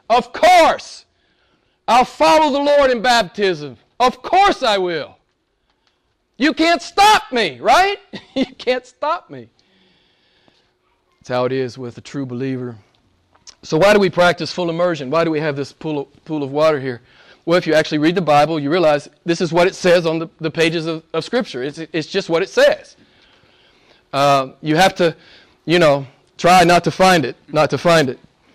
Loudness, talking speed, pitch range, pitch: -16 LUFS, 175 wpm, 145-240 Hz, 170 Hz